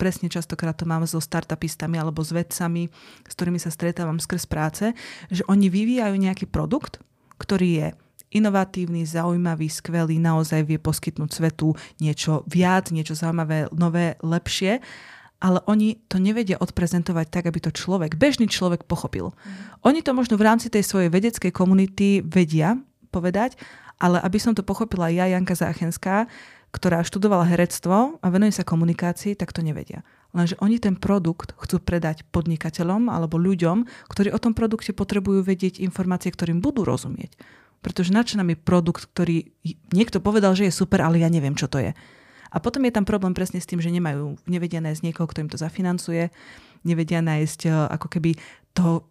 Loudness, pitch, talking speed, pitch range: -23 LUFS, 175 Hz, 165 wpm, 165-195 Hz